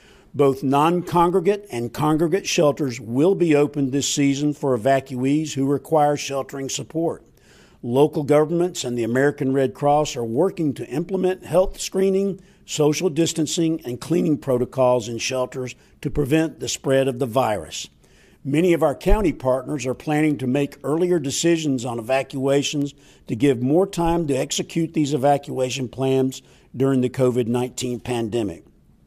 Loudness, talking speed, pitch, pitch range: -21 LUFS, 145 wpm, 140 Hz, 130-160 Hz